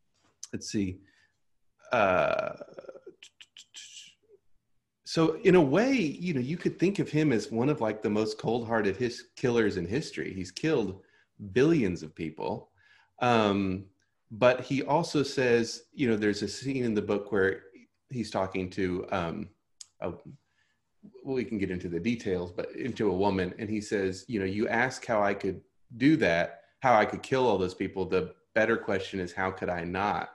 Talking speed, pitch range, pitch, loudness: 180 wpm, 95-140 Hz, 110 Hz, -29 LUFS